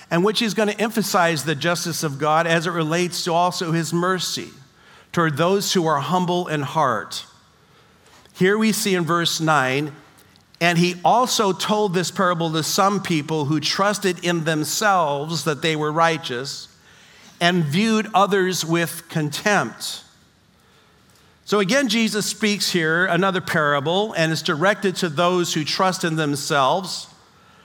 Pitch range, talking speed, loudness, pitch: 160-195 Hz, 150 wpm, -20 LUFS, 170 Hz